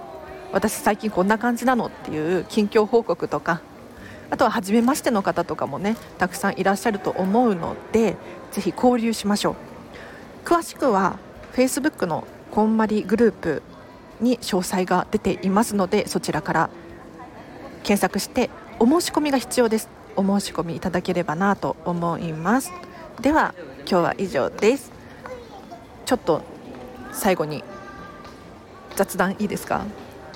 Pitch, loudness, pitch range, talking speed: 205 Hz, -22 LUFS, 180-235 Hz, 295 characters per minute